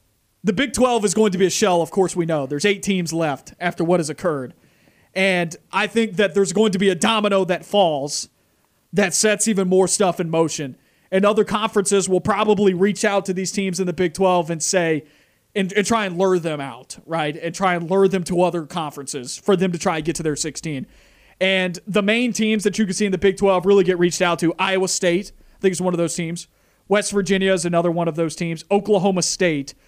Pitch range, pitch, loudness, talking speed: 170-200 Hz, 185 Hz, -20 LUFS, 235 wpm